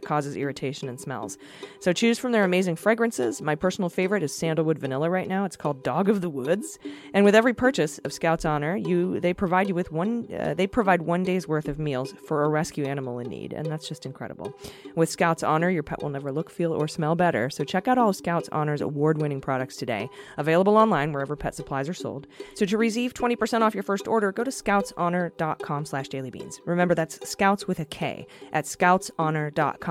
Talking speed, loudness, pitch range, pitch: 205 wpm, -25 LUFS, 145-195 Hz, 165 Hz